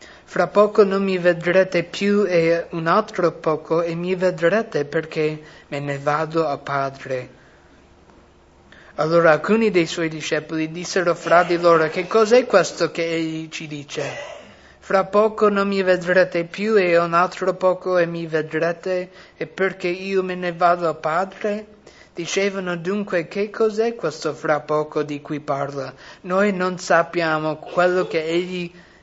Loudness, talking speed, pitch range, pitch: -20 LUFS, 150 wpm, 160-185 Hz, 175 Hz